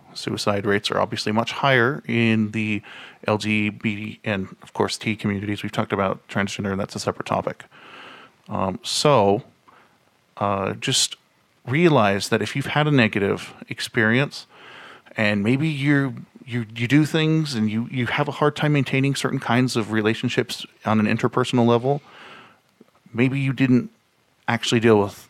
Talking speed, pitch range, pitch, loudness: 150 wpm, 105-135 Hz, 115 Hz, -22 LUFS